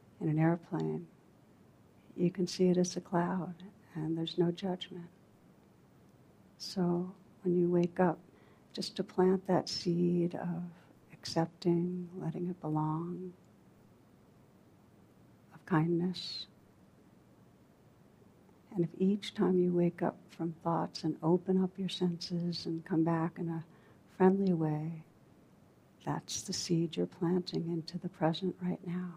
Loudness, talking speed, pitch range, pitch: -34 LUFS, 130 wpm, 165-180 Hz, 175 Hz